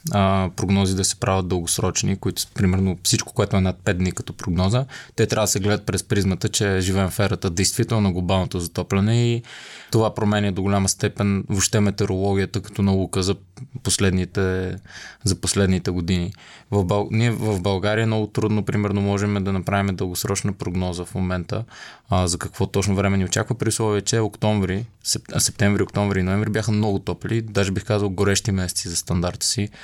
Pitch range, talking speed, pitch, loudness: 95-105 Hz, 175 wpm, 100 Hz, -22 LUFS